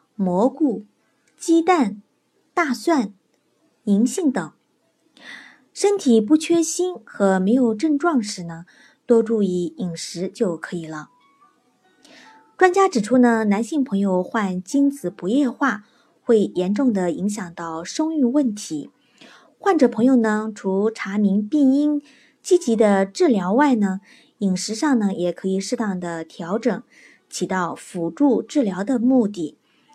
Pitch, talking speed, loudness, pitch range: 230 Hz, 190 characters per minute, -20 LUFS, 195-280 Hz